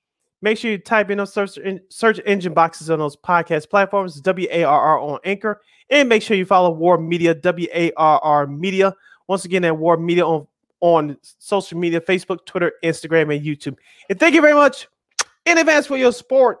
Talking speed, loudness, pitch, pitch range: 175 wpm, -17 LUFS, 185 Hz, 165-205 Hz